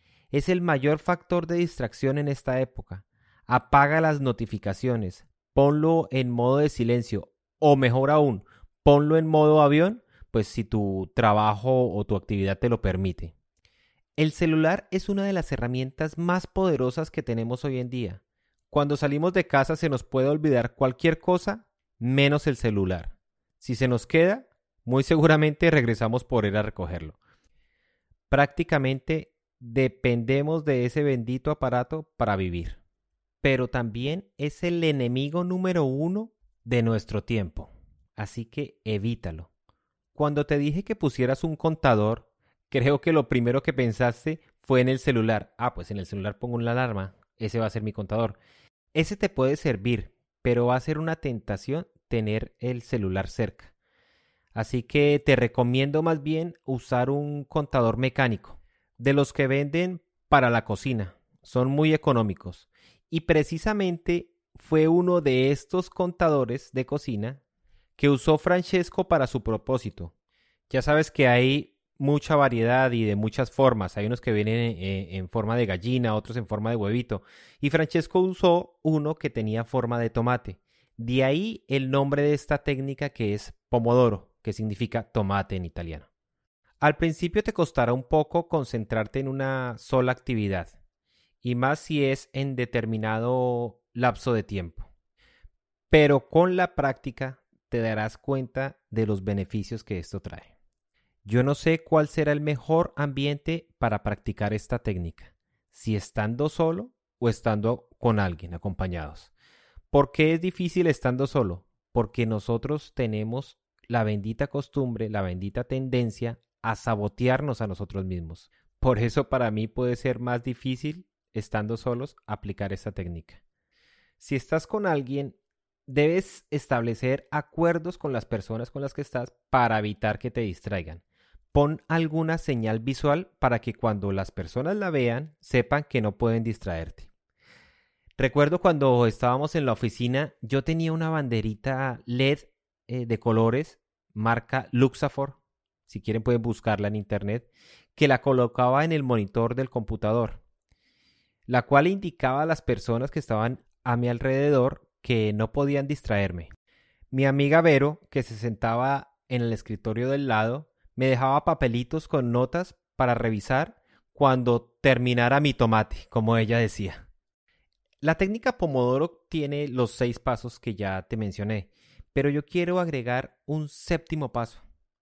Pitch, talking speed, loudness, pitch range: 125 Hz, 145 wpm, -26 LUFS, 110-145 Hz